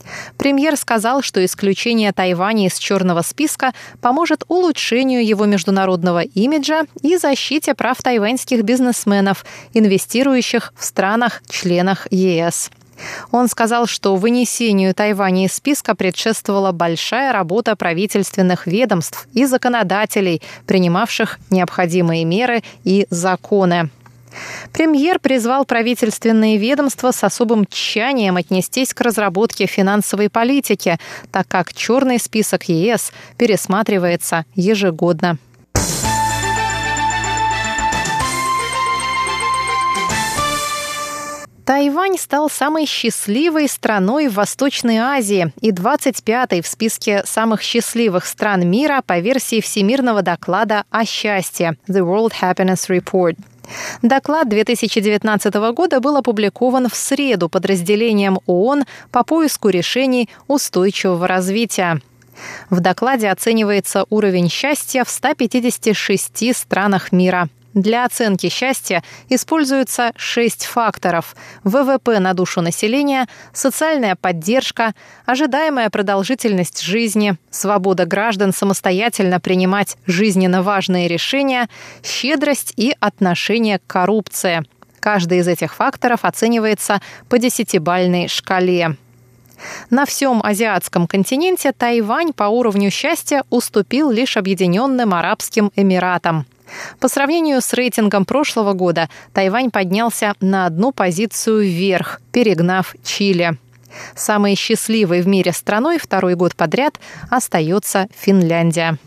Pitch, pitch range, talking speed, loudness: 210 Hz, 185-250 Hz, 100 wpm, -16 LUFS